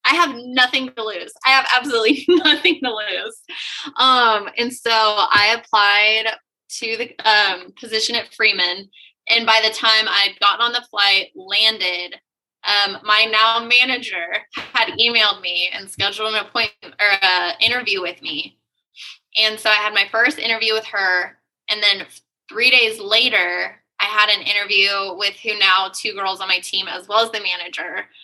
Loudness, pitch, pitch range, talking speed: -16 LUFS, 220 Hz, 200-235 Hz, 170 wpm